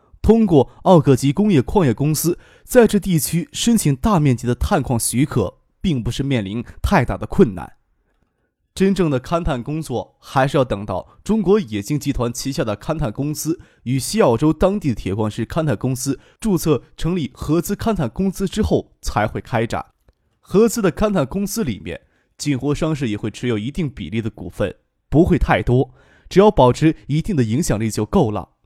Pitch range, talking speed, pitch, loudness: 120-180 Hz, 275 characters per minute, 145 Hz, -19 LUFS